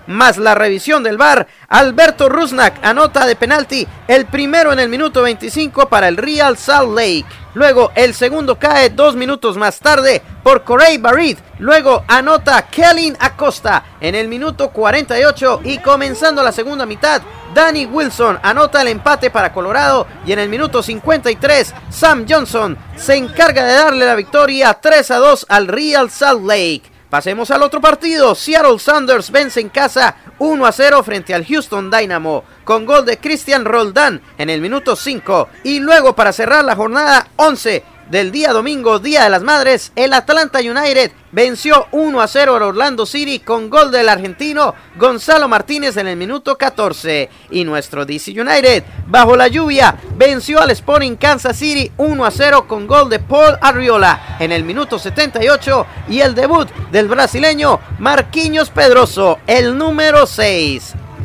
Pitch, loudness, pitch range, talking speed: 270 Hz, -11 LUFS, 230-295 Hz, 160 wpm